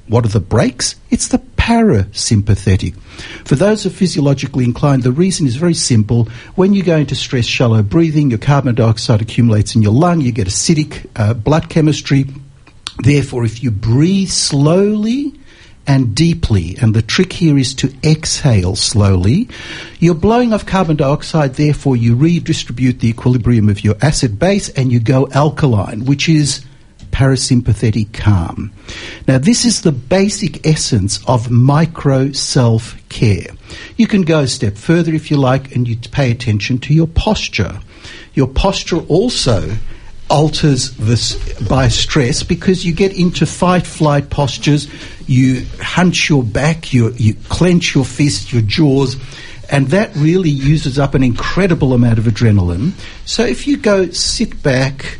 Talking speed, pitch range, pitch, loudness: 155 wpm, 115-160 Hz, 135 Hz, -13 LUFS